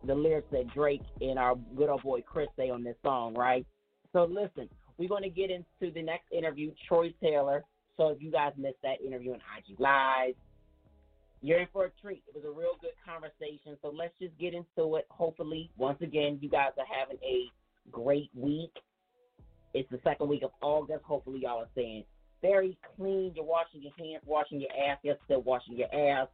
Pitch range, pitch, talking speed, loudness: 130-170 Hz, 145 Hz, 200 wpm, -33 LUFS